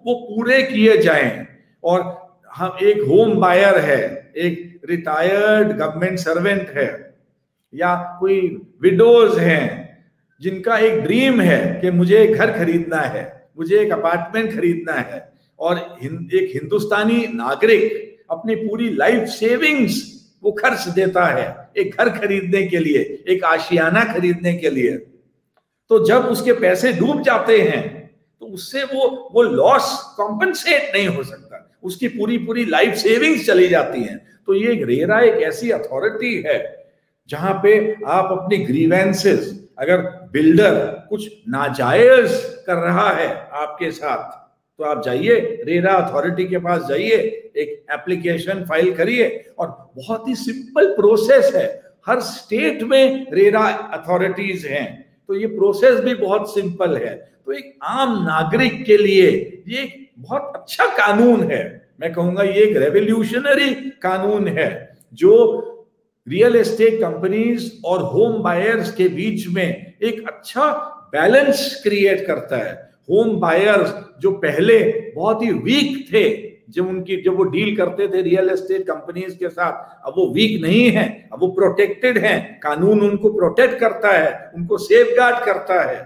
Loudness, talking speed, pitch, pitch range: -17 LUFS, 140 wpm, 210 Hz, 180-250 Hz